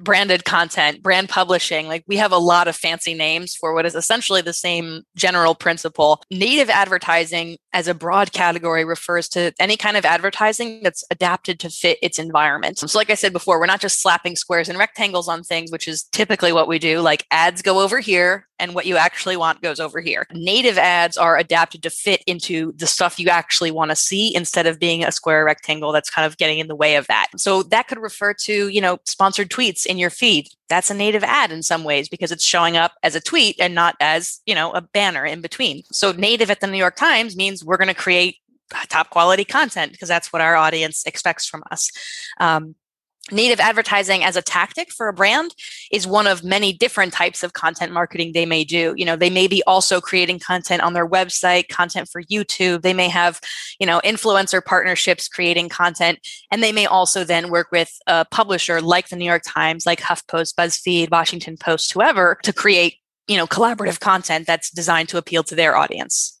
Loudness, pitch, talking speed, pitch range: -17 LUFS, 175 Hz, 210 wpm, 165-195 Hz